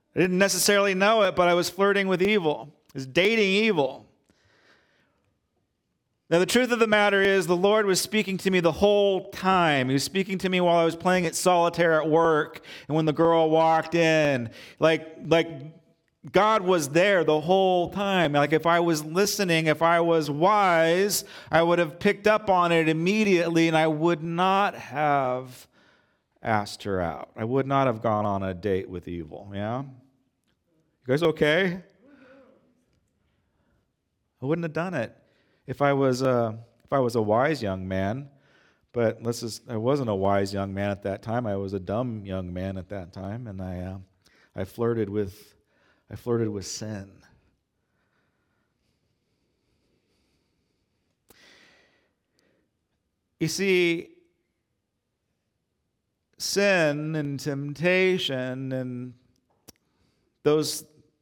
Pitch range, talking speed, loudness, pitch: 115-180 Hz, 145 wpm, -24 LUFS, 155 Hz